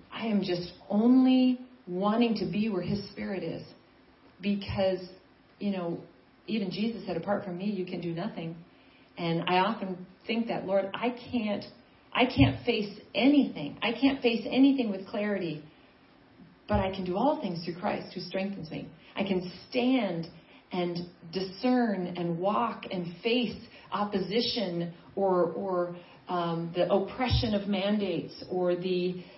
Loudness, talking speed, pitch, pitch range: -30 LUFS, 145 wpm, 195 Hz, 180-220 Hz